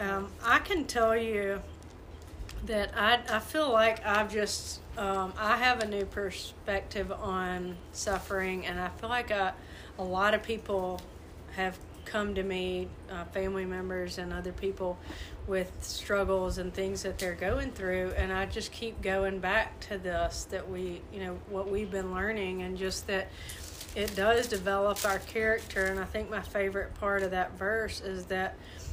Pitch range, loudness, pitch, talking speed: 185-210 Hz, -32 LUFS, 195 Hz, 165 wpm